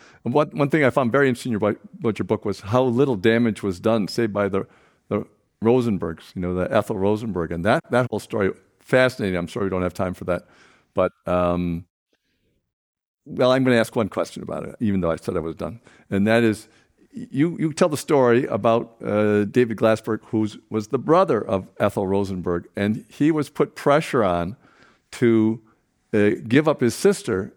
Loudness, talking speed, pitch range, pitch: -22 LUFS, 195 wpm, 100-125 Hz, 110 Hz